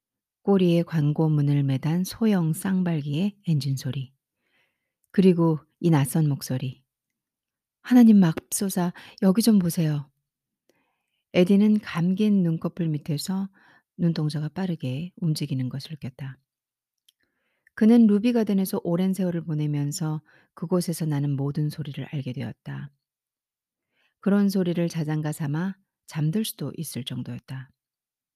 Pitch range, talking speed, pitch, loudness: 145-185 Hz, 250 characters per minute, 160 Hz, -24 LUFS